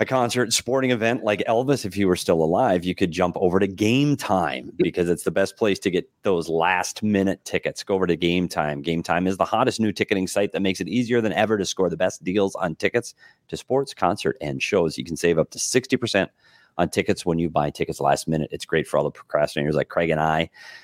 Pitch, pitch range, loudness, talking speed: 95 Hz, 85-115 Hz, -23 LUFS, 240 wpm